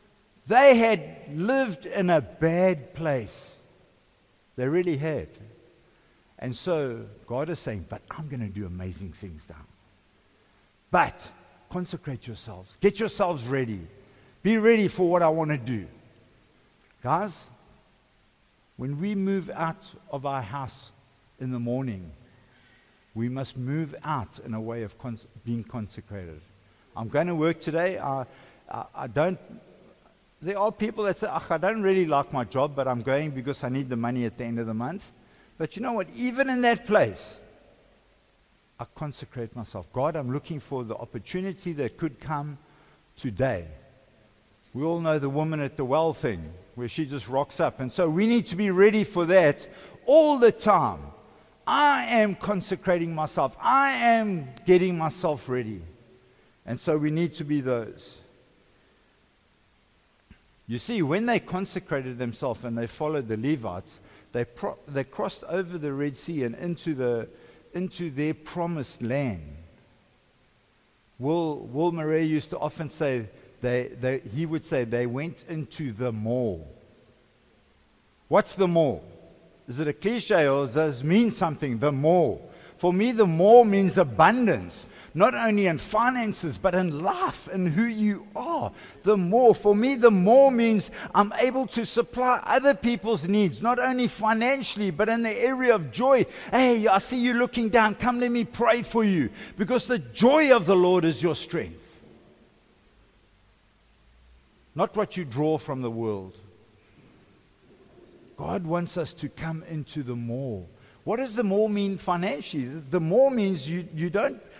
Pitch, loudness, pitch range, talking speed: 155 Hz, -25 LUFS, 120-195 Hz, 160 wpm